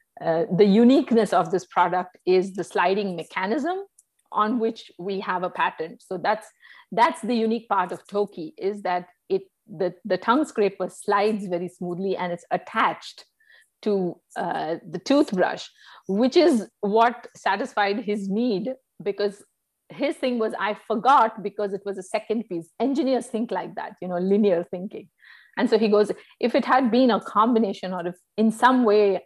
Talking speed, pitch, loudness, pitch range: 170 wpm, 205 Hz, -24 LUFS, 185-235 Hz